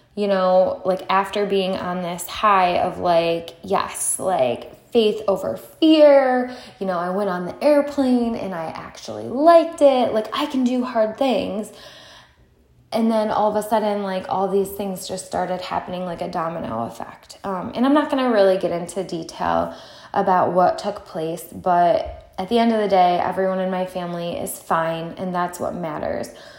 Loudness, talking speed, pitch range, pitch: -20 LUFS, 185 wpm, 180-235 Hz, 195 Hz